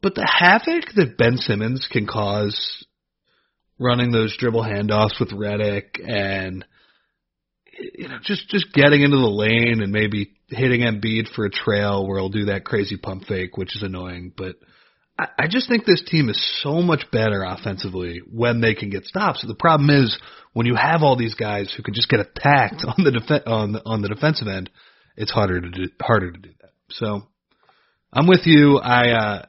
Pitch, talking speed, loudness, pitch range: 110 Hz, 195 wpm, -19 LUFS, 100-135 Hz